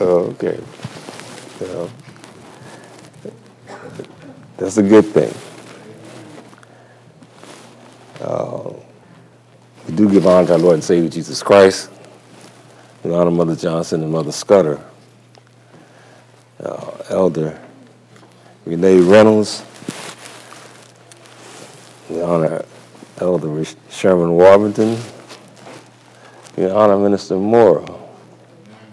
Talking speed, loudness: 80 wpm, -15 LUFS